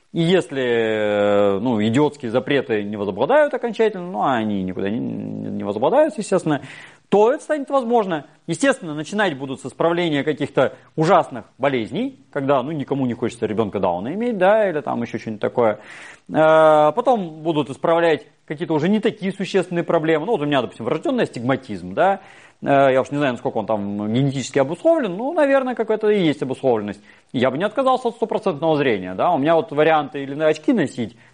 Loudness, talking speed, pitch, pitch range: -20 LUFS, 170 wpm, 155 Hz, 130-195 Hz